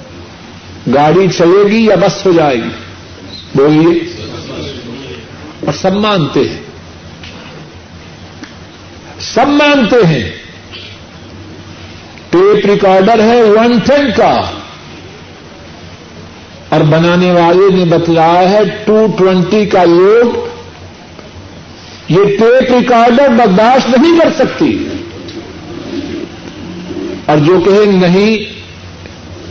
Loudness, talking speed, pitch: -9 LUFS, 85 wpm, 175 Hz